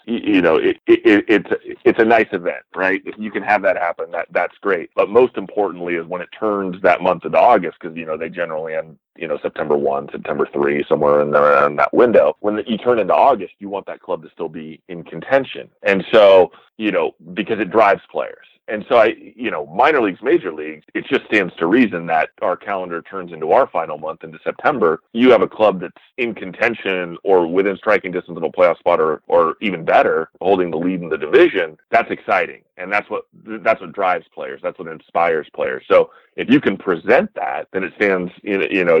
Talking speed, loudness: 225 wpm, -17 LUFS